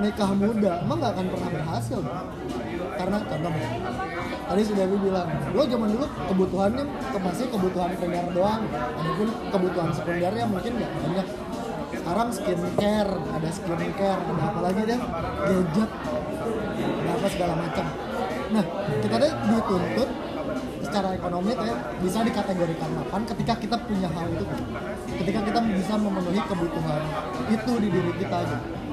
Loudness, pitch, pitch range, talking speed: -26 LUFS, 195 Hz, 180-215 Hz, 135 wpm